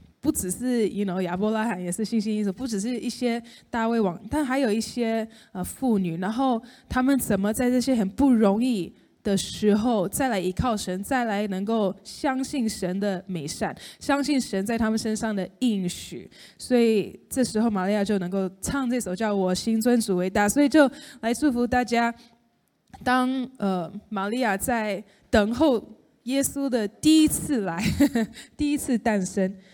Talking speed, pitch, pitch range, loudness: 260 characters per minute, 225 Hz, 200-250 Hz, -25 LUFS